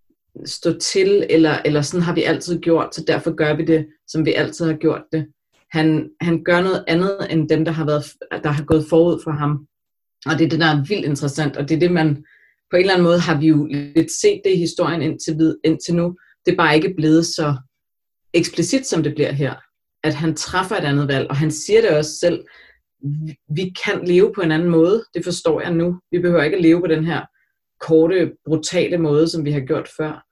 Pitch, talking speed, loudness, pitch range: 160 Hz, 230 wpm, -18 LUFS, 155-170 Hz